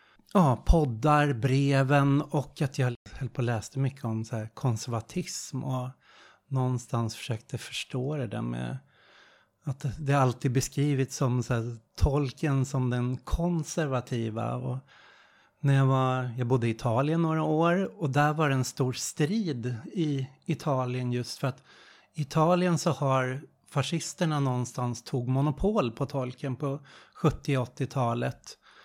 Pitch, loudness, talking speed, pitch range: 135 Hz, -29 LUFS, 135 wpm, 125-150 Hz